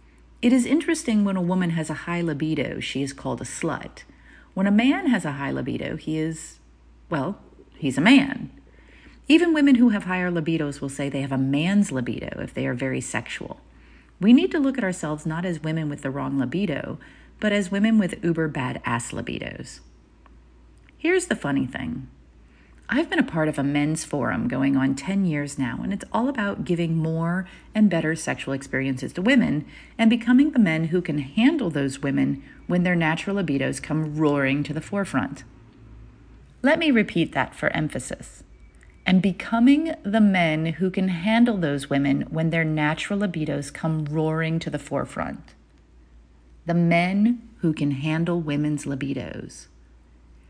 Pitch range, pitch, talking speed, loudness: 140-200 Hz, 160 Hz, 170 wpm, -23 LUFS